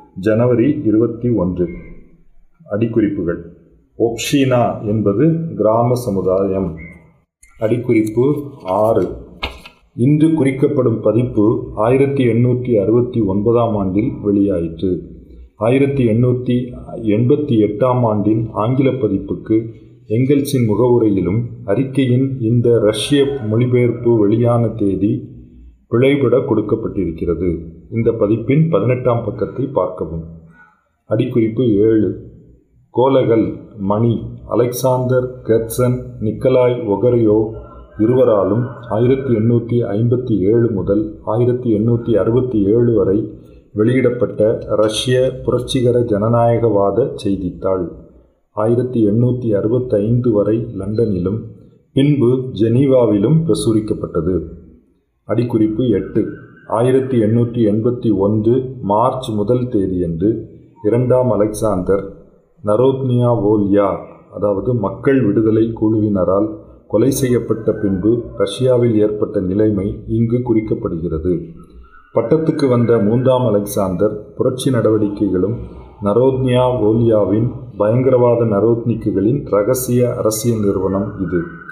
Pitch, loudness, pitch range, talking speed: 115 Hz, -16 LUFS, 100-125 Hz, 80 wpm